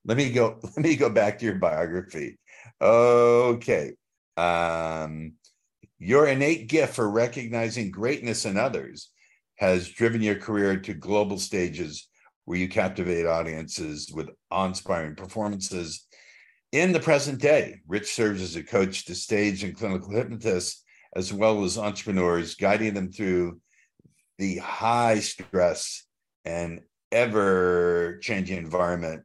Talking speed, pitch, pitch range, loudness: 125 wpm, 95 Hz, 90-115 Hz, -25 LUFS